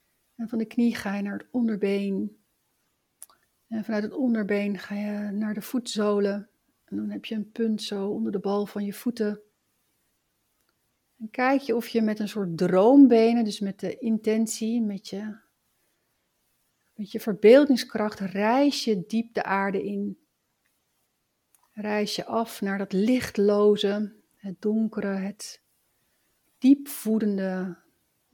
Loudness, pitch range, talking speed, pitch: -25 LUFS, 200-225 Hz, 140 wpm, 210 Hz